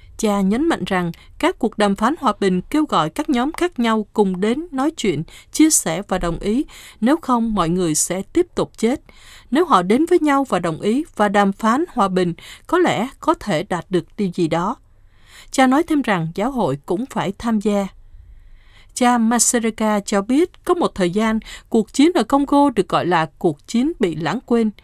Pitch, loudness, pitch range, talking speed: 215 Hz, -19 LUFS, 185-275 Hz, 205 wpm